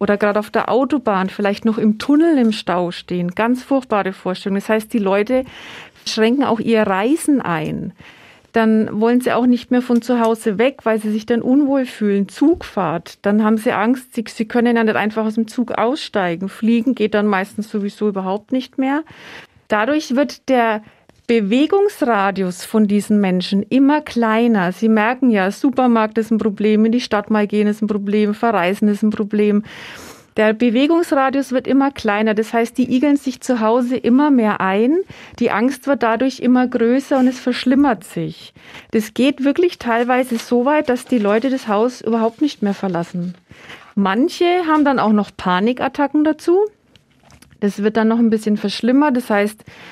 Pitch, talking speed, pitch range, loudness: 225 Hz, 175 wpm, 210-255 Hz, -17 LUFS